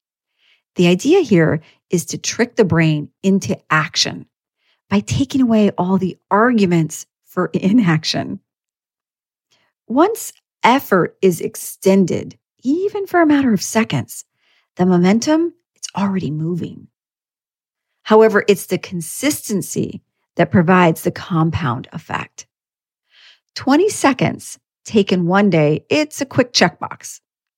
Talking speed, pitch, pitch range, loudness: 110 wpm, 195 Hz, 175-245 Hz, -16 LUFS